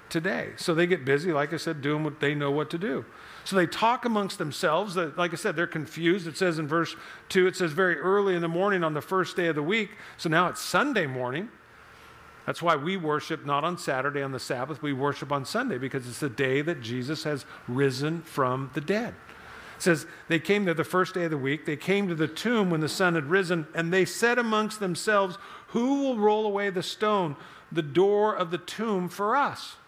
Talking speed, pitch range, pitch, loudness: 225 wpm, 150-195 Hz, 170 Hz, -27 LUFS